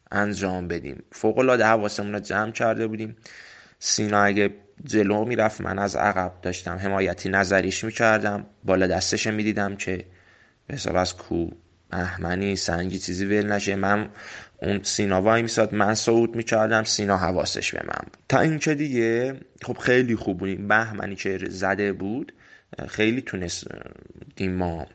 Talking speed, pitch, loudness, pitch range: 145 wpm, 100 Hz, -24 LUFS, 95-110 Hz